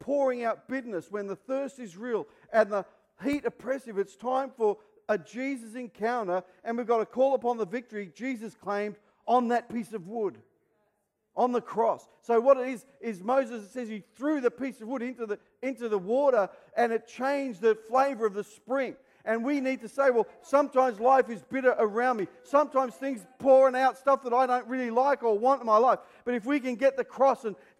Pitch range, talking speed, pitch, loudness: 220-265 Hz, 215 wpm, 245 Hz, -28 LUFS